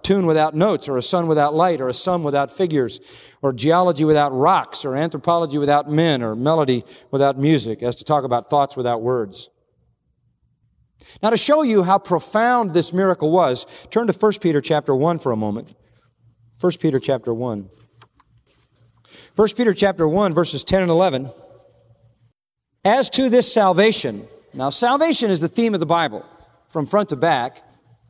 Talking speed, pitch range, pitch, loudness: 165 wpm, 125-185 Hz, 155 Hz, -18 LUFS